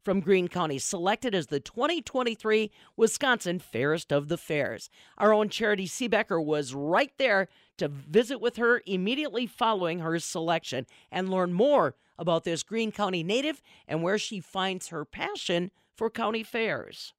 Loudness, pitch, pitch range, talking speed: -28 LUFS, 195 Hz, 170-225 Hz, 155 wpm